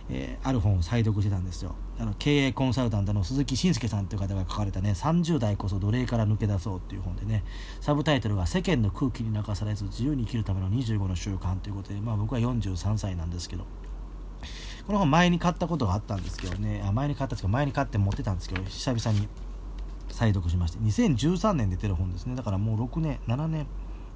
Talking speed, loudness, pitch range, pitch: 440 characters per minute, -28 LUFS, 95-125 Hz, 105 Hz